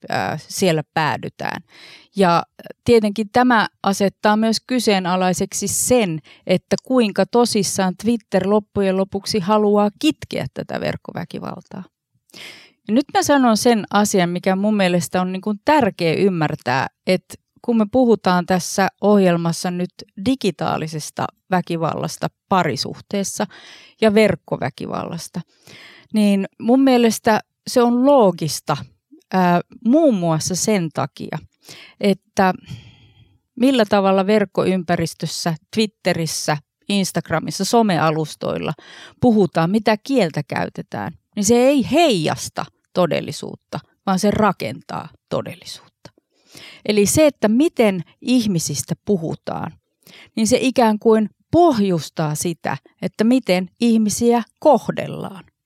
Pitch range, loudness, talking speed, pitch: 180-230 Hz, -18 LUFS, 95 wpm, 200 Hz